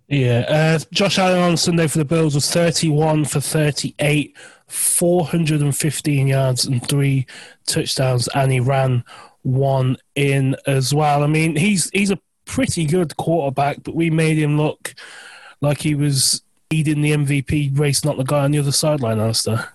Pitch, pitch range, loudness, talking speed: 150 Hz, 135-160 Hz, -18 LUFS, 160 wpm